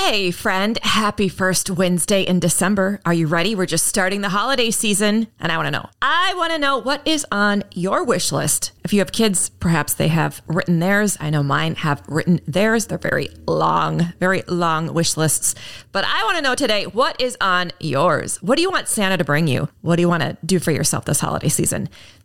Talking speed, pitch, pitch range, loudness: 210 wpm, 180 Hz, 160-205 Hz, -19 LUFS